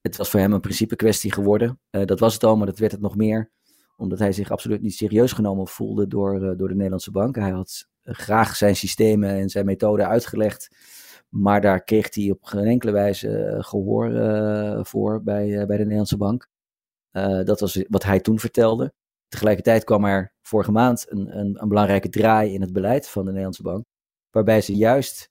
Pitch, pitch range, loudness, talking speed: 105 Hz, 100-110 Hz, -21 LUFS, 200 wpm